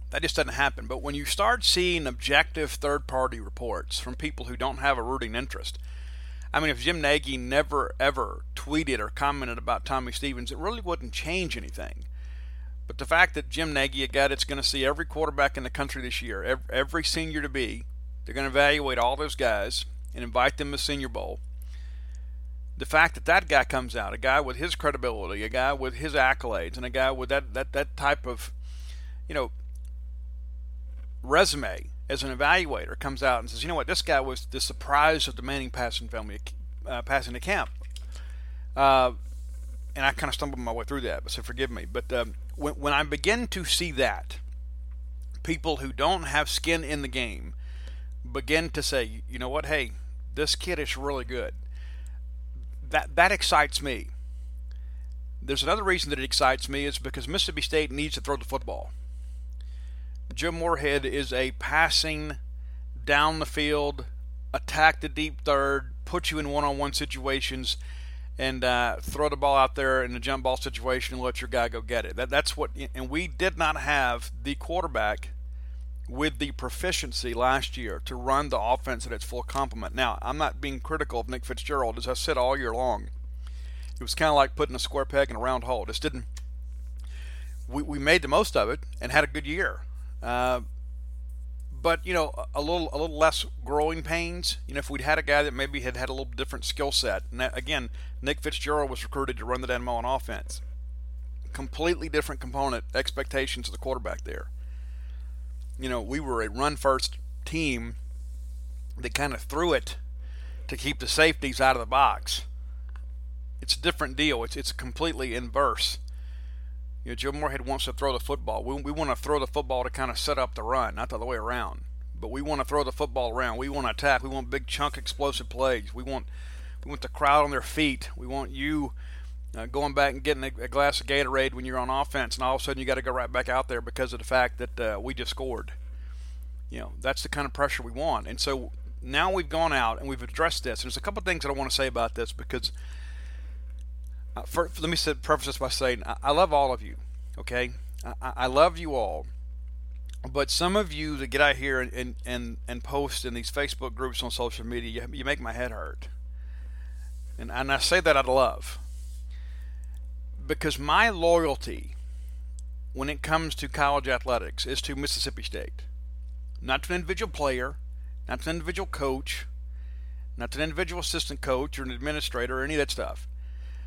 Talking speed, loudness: 200 wpm, -27 LUFS